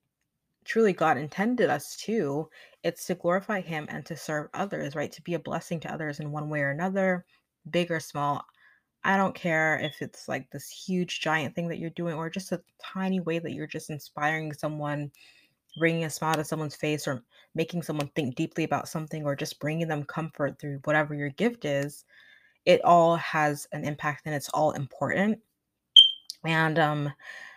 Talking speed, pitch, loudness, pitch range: 185 wpm, 160 Hz, -27 LUFS, 150-170 Hz